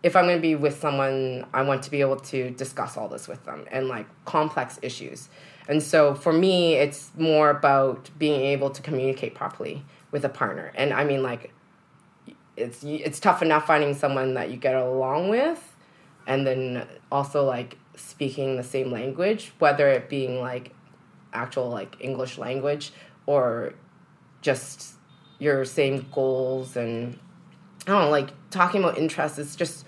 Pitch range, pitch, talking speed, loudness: 130-155 Hz, 140 Hz, 165 wpm, -25 LUFS